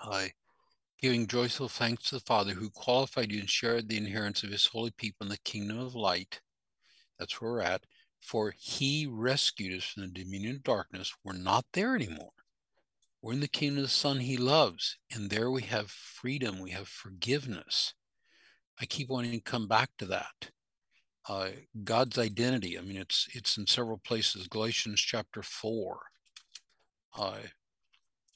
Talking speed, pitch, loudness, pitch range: 170 wpm, 115 Hz, -32 LUFS, 100-125 Hz